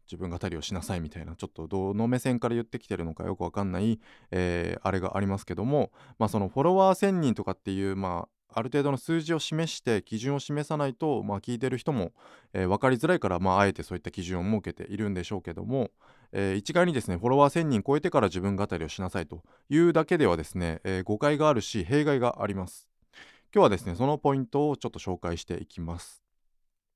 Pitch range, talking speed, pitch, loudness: 90-135 Hz, 465 characters per minute, 100 Hz, -28 LUFS